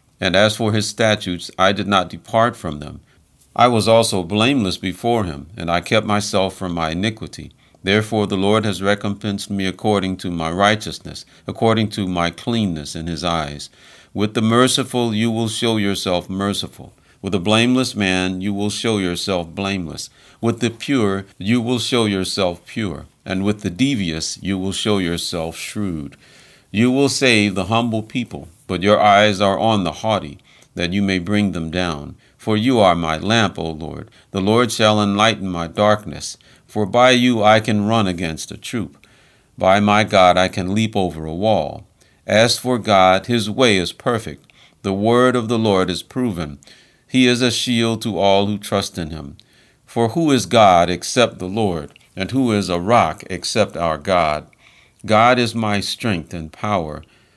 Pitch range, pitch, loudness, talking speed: 90-115 Hz, 100 Hz, -18 LUFS, 180 wpm